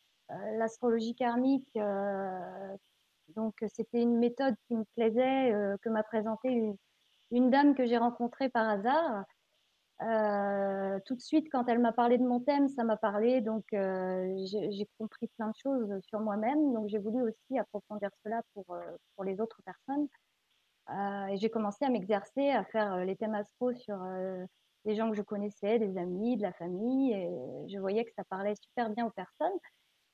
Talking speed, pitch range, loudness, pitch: 180 wpm, 200-240 Hz, -33 LUFS, 220 Hz